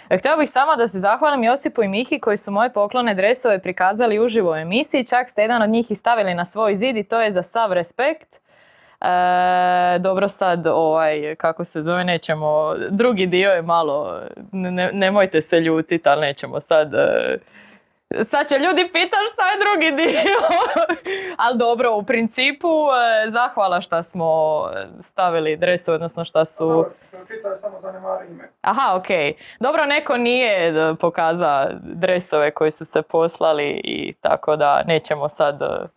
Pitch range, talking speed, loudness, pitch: 165-245 Hz, 150 wpm, -19 LUFS, 195 Hz